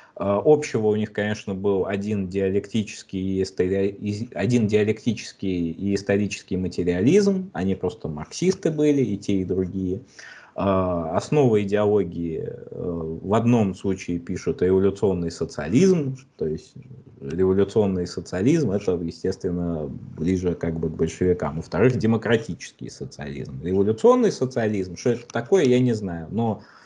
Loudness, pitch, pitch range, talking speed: -23 LUFS, 100 Hz, 90-115 Hz, 115 wpm